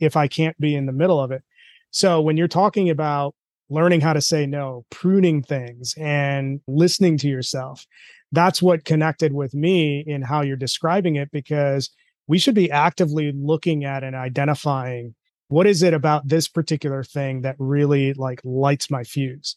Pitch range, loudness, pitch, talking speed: 135-165 Hz, -20 LUFS, 150 Hz, 175 wpm